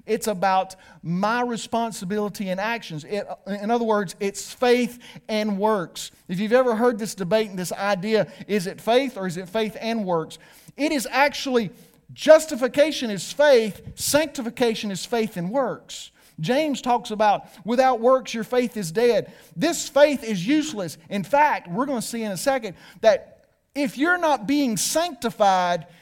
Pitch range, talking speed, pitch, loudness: 195-255 Hz, 165 wpm, 220 Hz, -23 LUFS